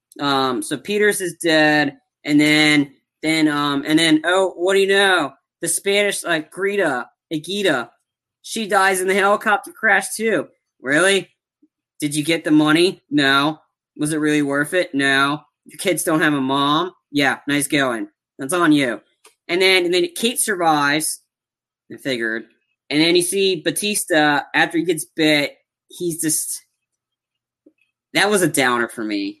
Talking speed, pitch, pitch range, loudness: 160 wpm, 160 Hz, 145-195 Hz, -18 LUFS